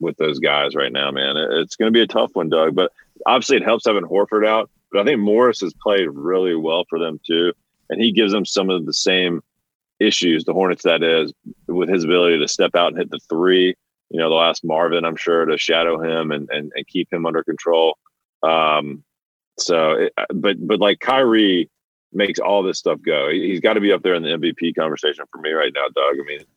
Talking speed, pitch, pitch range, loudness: 230 wpm, 85 Hz, 80-90 Hz, -18 LUFS